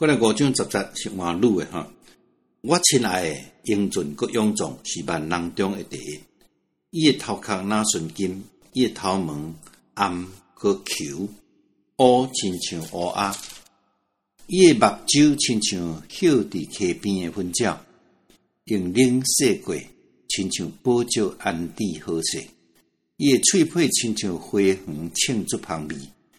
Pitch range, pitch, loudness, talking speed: 85-115 Hz, 100 Hz, -22 LUFS, 190 characters per minute